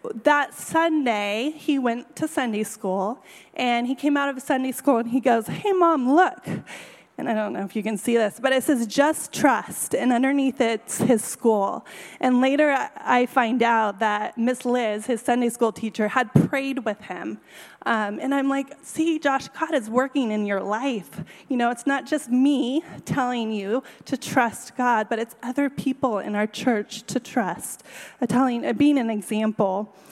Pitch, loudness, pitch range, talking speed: 245 Hz, -23 LUFS, 220-275 Hz, 185 wpm